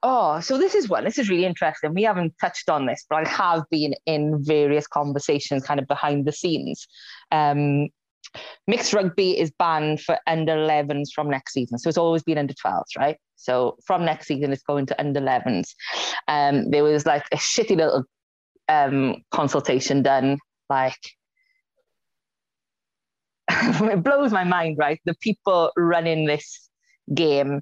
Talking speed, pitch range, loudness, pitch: 165 wpm, 145-175 Hz, -22 LUFS, 155 Hz